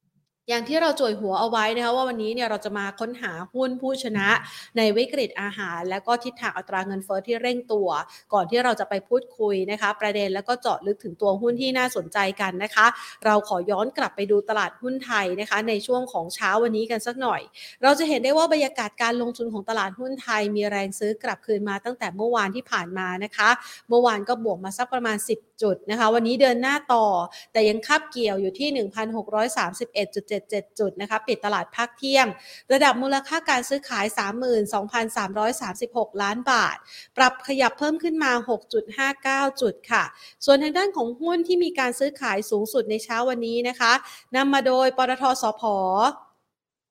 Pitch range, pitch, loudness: 205-255 Hz, 230 Hz, -24 LUFS